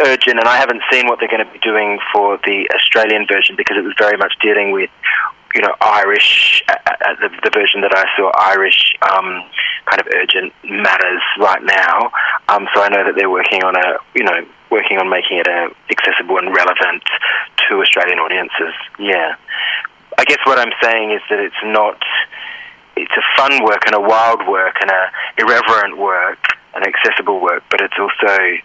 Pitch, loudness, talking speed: 110 Hz, -12 LUFS, 190 wpm